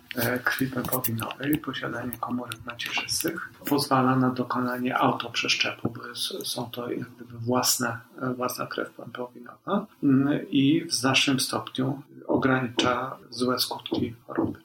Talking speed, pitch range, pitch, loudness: 100 wpm, 125-135 Hz, 125 Hz, -26 LUFS